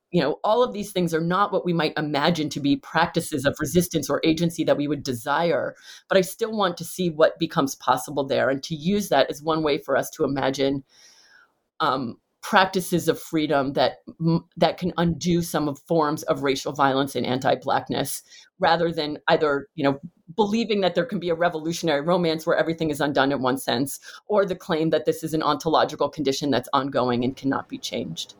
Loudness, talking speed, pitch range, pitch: -23 LUFS, 200 wpm, 140-170 Hz, 160 Hz